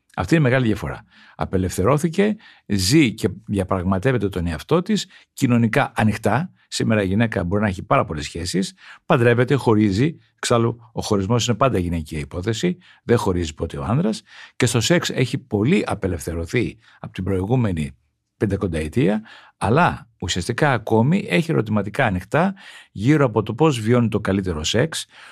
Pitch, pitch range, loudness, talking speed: 110 Hz, 95-135 Hz, -20 LUFS, 145 wpm